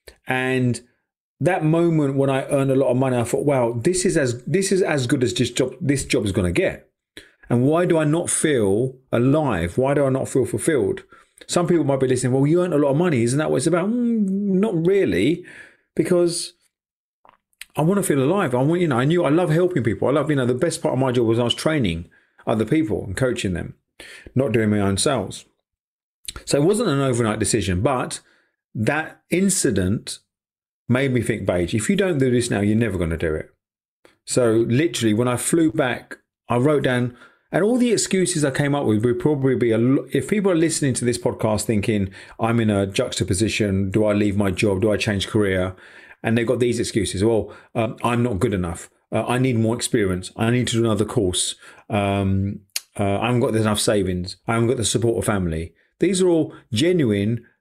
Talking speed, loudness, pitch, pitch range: 220 wpm, -20 LUFS, 125 Hz, 110-155 Hz